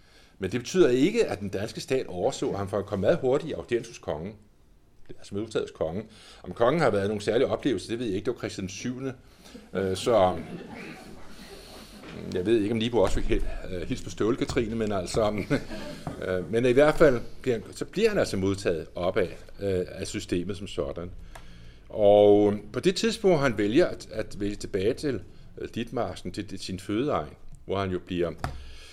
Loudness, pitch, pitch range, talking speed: -27 LUFS, 100 Hz, 90-110 Hz, 175 wpm